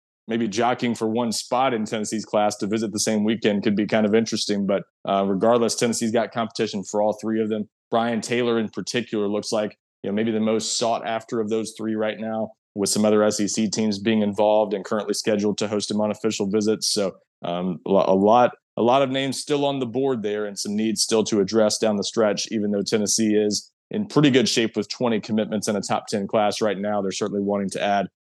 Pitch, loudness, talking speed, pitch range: 110 Hz, -22 LUFS, 230 wpm, 105-115 Hz